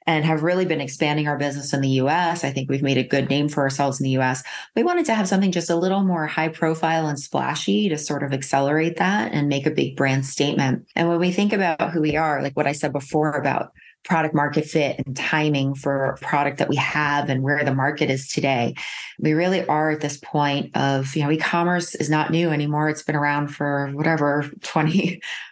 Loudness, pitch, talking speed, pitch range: -21 LUFS, 150 Hz, 230 wpm, 140-160 Hz